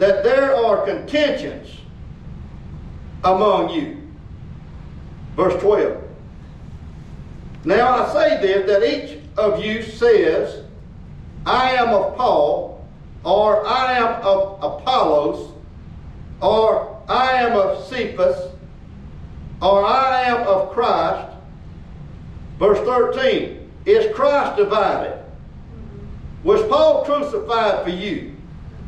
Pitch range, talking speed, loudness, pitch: 195-305 Hz, 95 wpm, -18 LUFS, 245 Hz